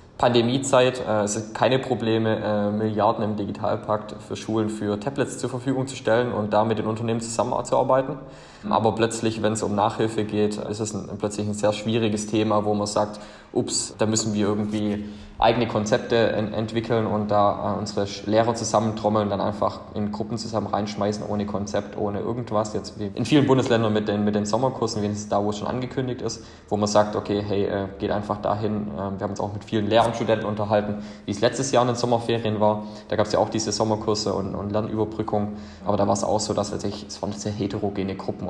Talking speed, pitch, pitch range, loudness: 210 wpm, 105 Hz, 105-110 Hz, -24 LUFS